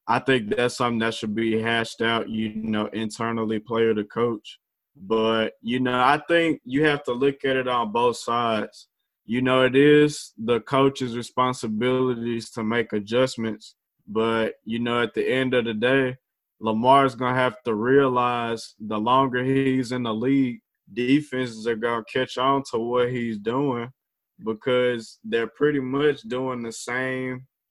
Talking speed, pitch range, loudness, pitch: 160 wpm, 115-130 Hz, -23 LUFS, 120 Hz